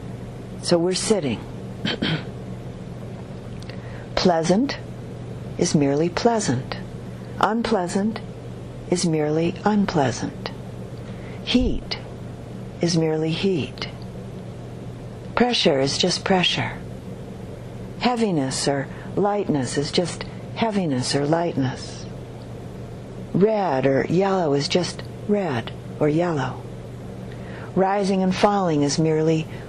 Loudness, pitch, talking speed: -22 LUFS, 140 Hz, 80 wpm